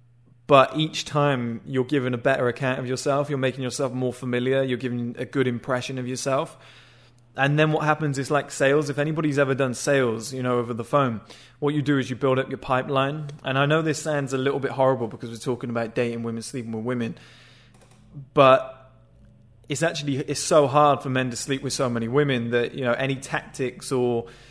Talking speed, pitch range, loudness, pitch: 210 wpm, 120-140 Hz, -24 LUFS, 130 Hz